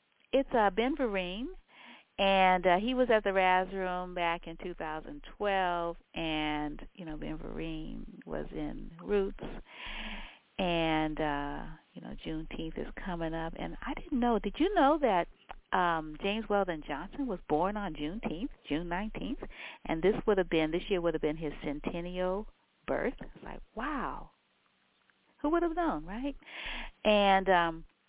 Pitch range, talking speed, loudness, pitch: 165-220 Hz, 160 wpm, -32 LUFS, 185 Hz